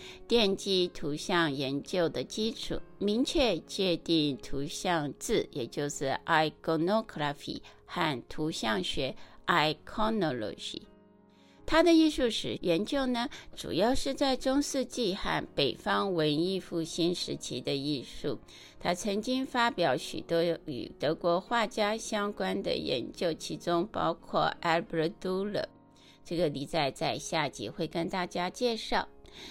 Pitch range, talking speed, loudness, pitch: 160-225 Hz, 235 characters per minute, -31 LUFS, 180 Hz